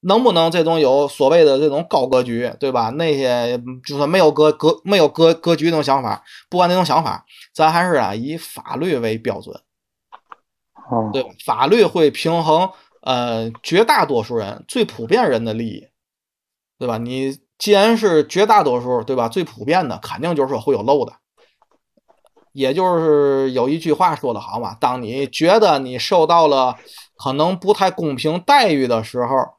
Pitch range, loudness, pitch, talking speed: 125-170 Hz, -17 LUFS, 145 Hz, 250 characters per minute